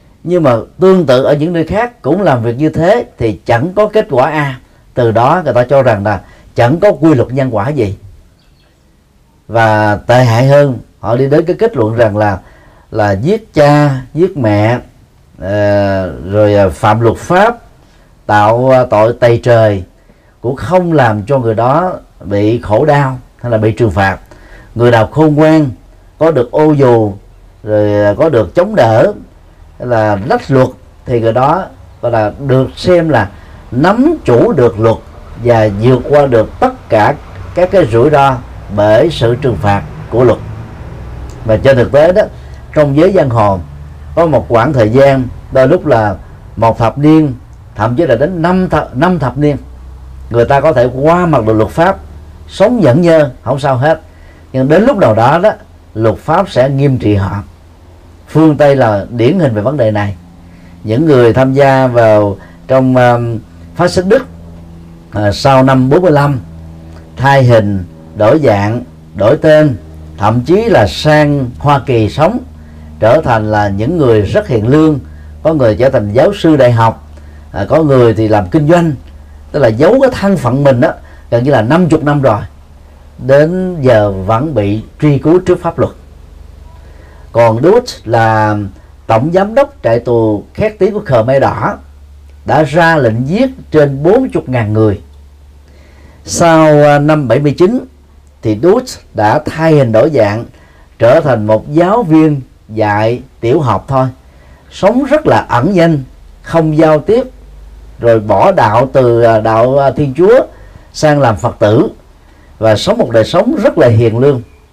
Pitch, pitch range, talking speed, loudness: 115 Hz, 95-145 Hz, 170 wpm, -10 LUFS